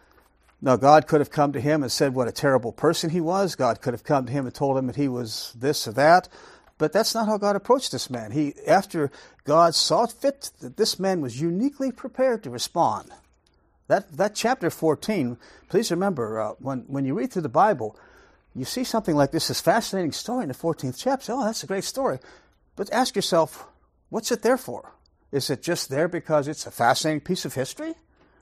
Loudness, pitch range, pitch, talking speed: -24 LUFS, 135-210 Hz, 160 Hz, 215 wpm